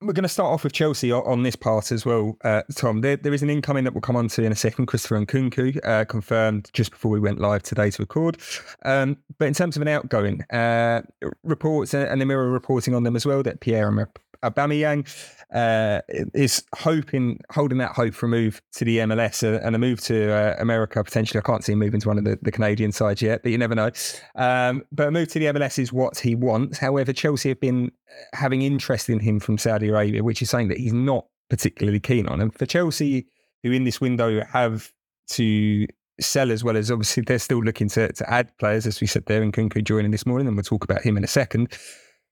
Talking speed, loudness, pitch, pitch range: 235 wpm, -23 LUFS, 120 Hz, 110-135 Hz